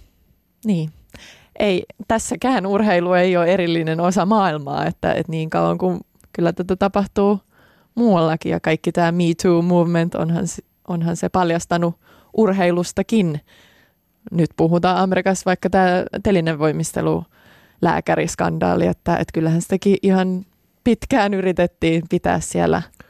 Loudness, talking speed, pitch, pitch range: -19 LUFS, 120 wpm, 180 Hz, 165-195 Hz